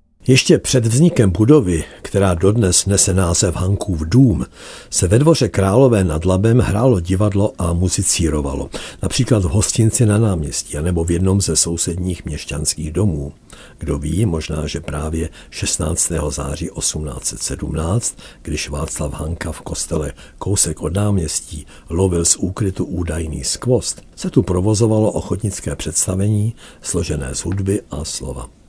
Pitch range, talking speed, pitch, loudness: 80-105 Hz, 130 wpm, 90 Hz, -17 LUFS